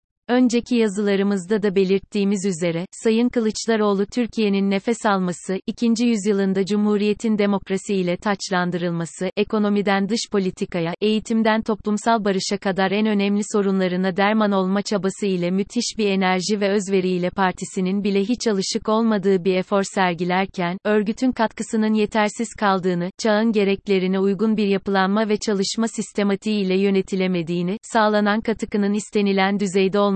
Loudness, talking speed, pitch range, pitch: -21 LUFS, 125 wpm, 190-215 Hz, 205 Hz